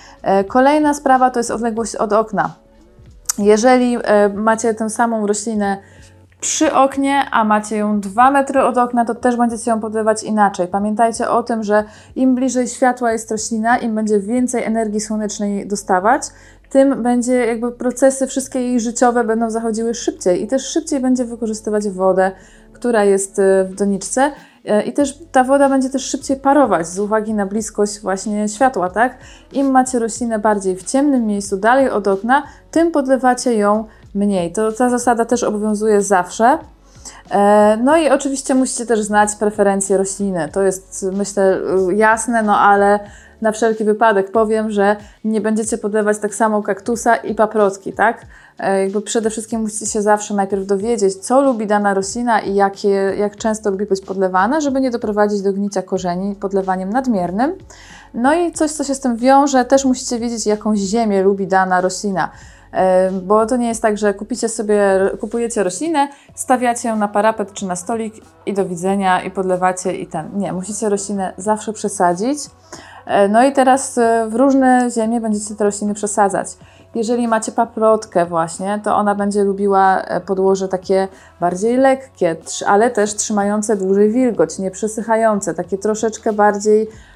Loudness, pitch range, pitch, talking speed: -16 LUFS, 200-245 Hz, 220 Hz, 160 wpm